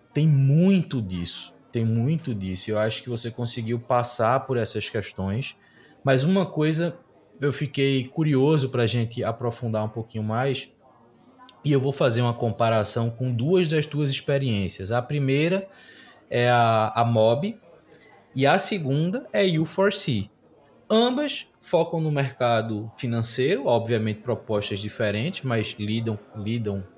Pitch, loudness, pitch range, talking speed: 125 Hz, -24 LUFS, 115-150 Hz, 140 wpm